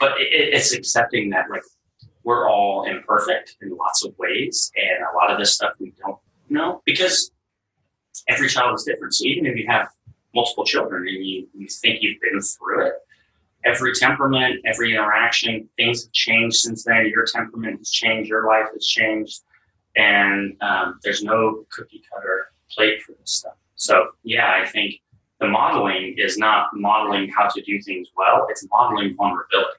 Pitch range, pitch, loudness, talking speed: 105-120 Hz, 110 Hz, -19 LUFS, 170 wpm